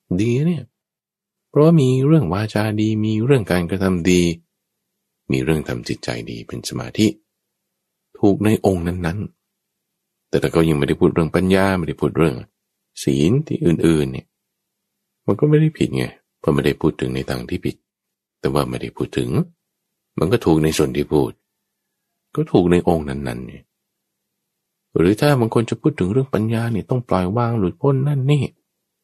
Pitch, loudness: 105 Hz, -19 LUFS